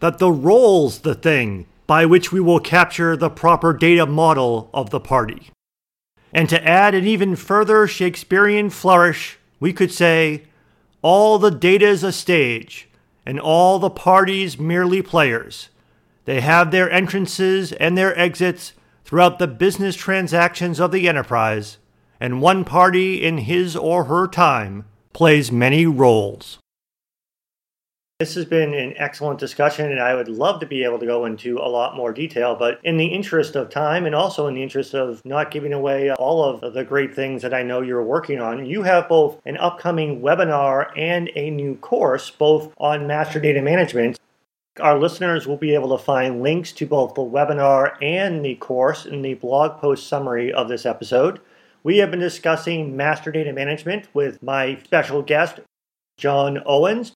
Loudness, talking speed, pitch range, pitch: -18 LUFS, 170 wpm, 135-180 Hz, 155 Hz